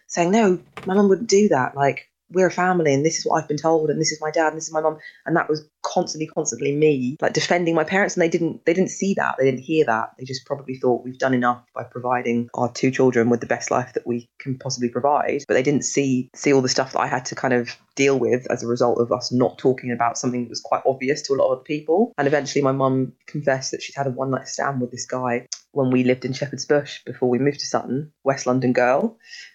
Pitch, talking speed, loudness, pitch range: 135 Hz, 270 wpm, -21 LUFS, 125-155 Hz